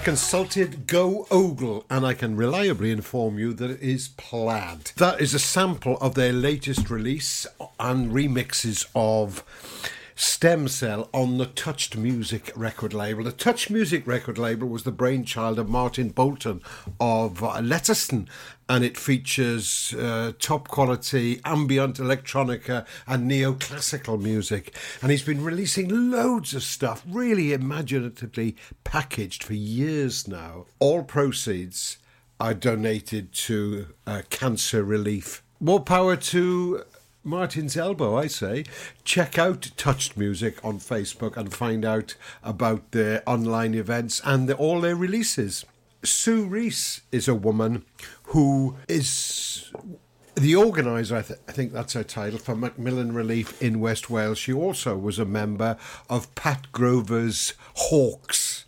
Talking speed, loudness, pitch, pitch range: 135 wpm, -25 LUFS, 125 Hz, 115-145 Hz